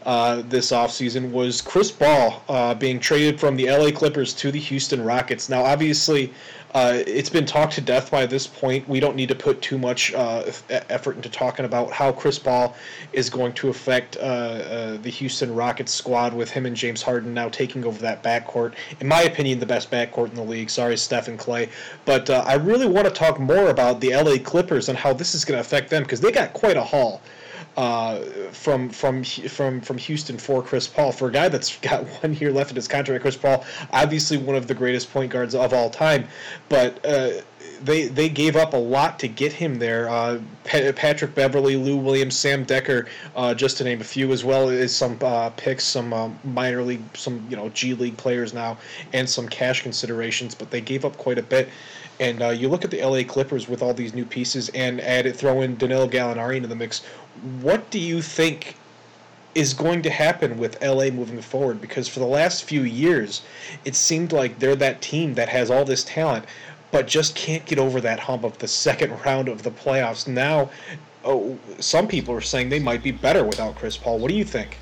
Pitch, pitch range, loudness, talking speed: 130 Hz, 125-140 Hz, -22 LUFS, 215 wpm